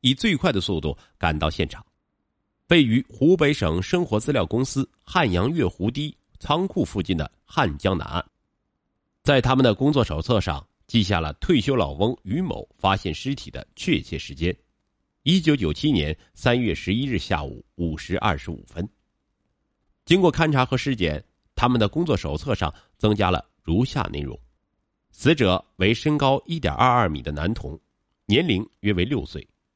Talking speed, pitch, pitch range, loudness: 245 characters per minute, 105 Hz, 85-130 Hz, -23 LUFS